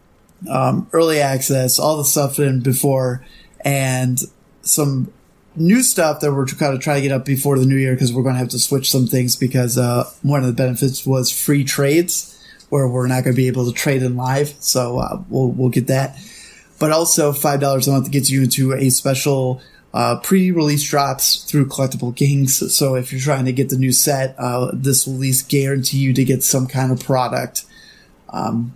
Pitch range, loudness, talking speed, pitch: 130-145 Hz, -17 LUFS, 205 wpm, 135 Hz